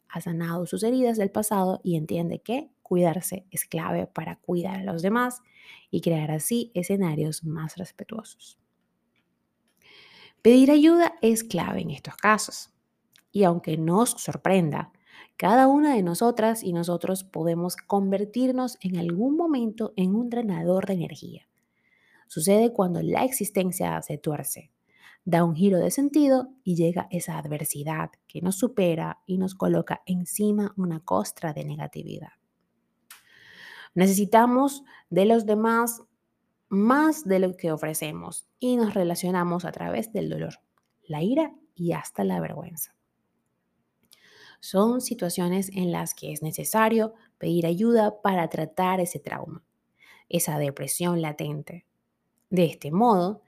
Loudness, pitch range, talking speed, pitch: -25 LUFS, 170-225 Hz, 130 wpm, 185 Hz